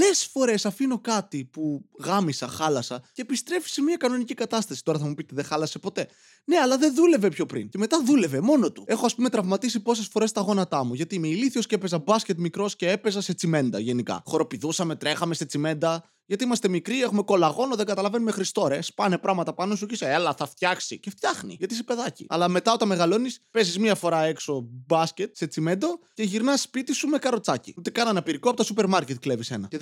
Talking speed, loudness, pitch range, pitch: 205 wpm, -25 LUFS, 160-235 Hz, 200 Hz